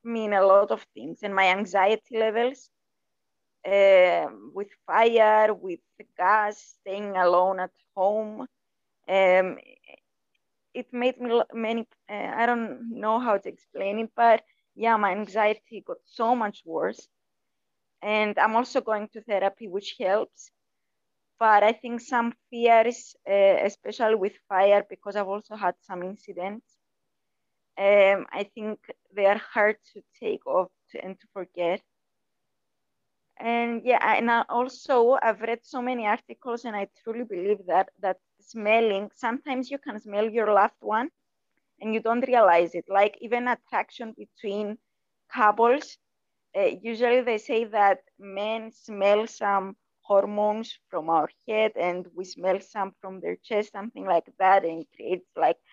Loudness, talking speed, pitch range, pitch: -25 LUFS, 145 wpm, 195-235 Hz, 215 Hz